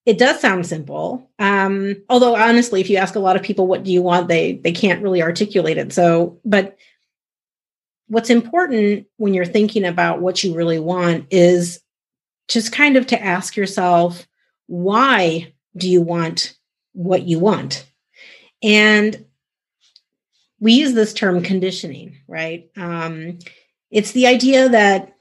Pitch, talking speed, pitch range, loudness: 190 Hz, 150 wpm, 175-215 Hz, -16 LUFS